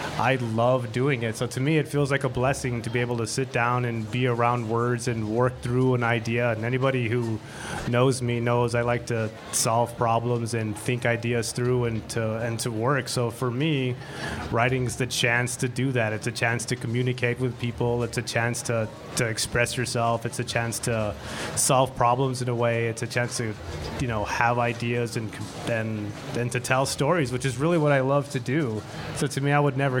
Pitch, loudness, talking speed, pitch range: 120 Hz, -25 LUFS, 215 wpm, 115-130 Hz